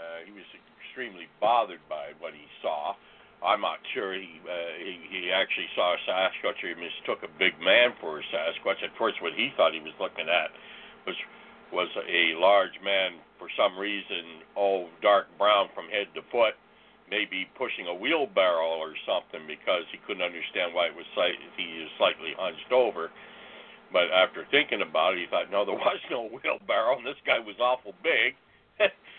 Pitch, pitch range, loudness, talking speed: 95 Hz, 85-100 Hz, -27 LUFS, 185 wpm